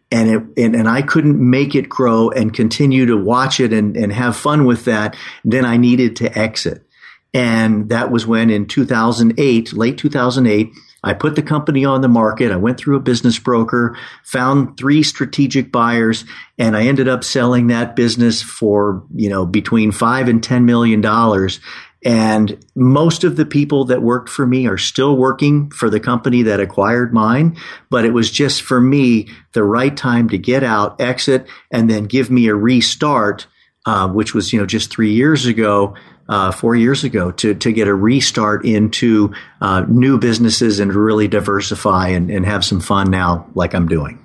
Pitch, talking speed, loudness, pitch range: 115 Hz, 185 wpm, -14 LUFS, 110-130 Hz